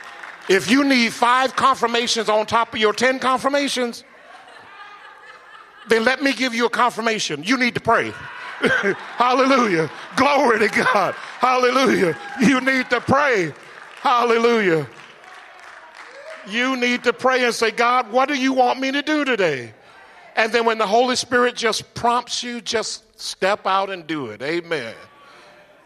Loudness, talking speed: -19 LUFS, 145 wpm